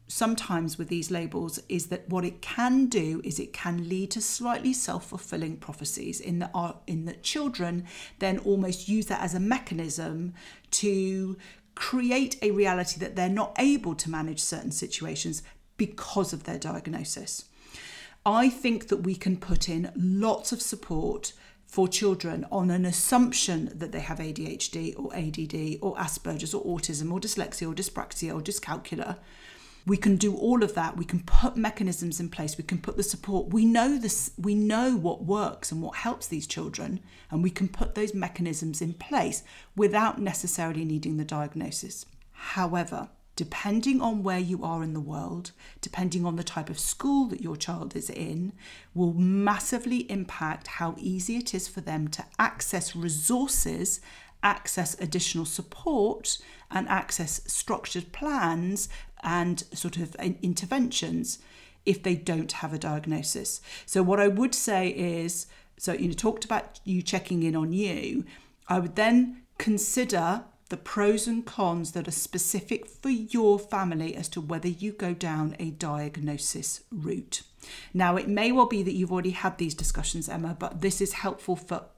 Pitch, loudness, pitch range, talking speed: 185 Hz, -29 LUFS, 170-205 Hz, 165 wpm